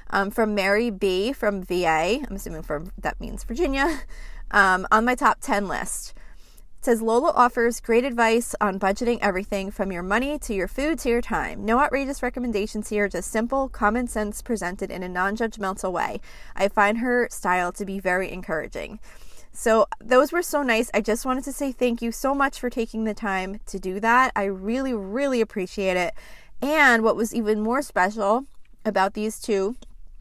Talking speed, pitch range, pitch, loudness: 185 wpm, 195-245 Hz, 215 Hz, -23 LUFS